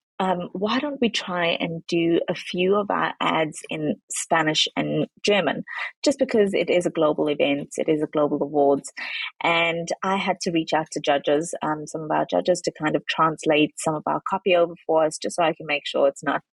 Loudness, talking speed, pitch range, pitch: -23 LUFS, 220 wpm, 155-185 Hz, 165 Hz